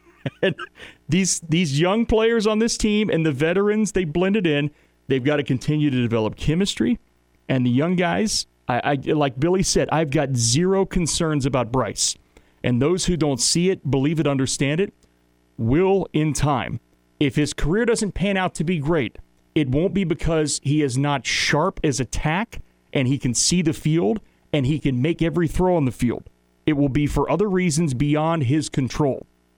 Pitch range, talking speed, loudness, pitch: 135-180 Hz, 185 wpm, -21 LUFS, 150 Hz